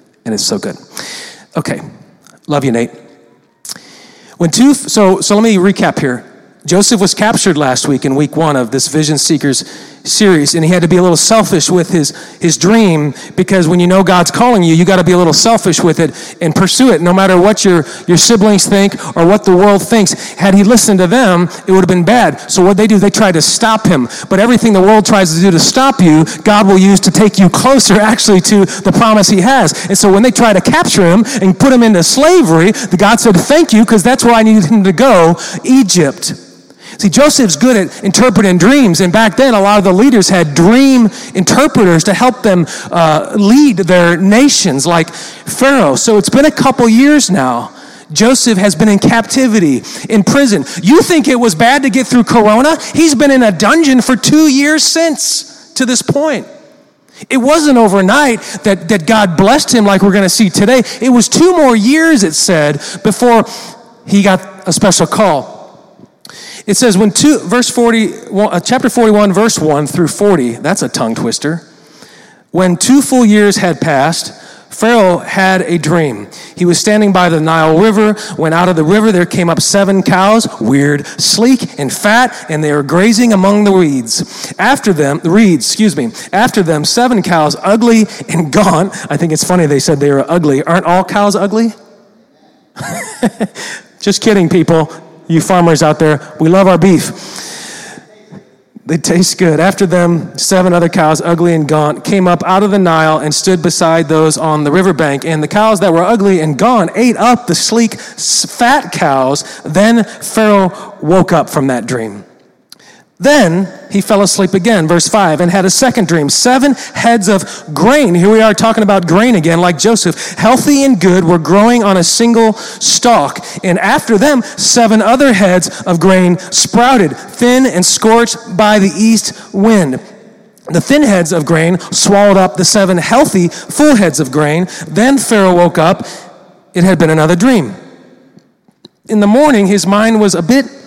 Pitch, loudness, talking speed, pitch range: 195 Hz, -9 LUFS, 190 wpm, 170-230 Hz